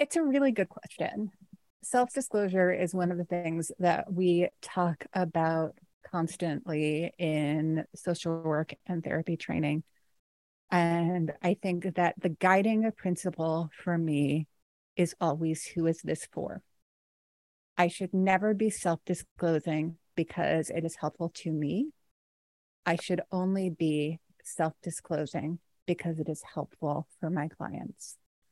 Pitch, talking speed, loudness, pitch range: 170 Hz, 135 wpm, -31 LUFS, 160-185 Hz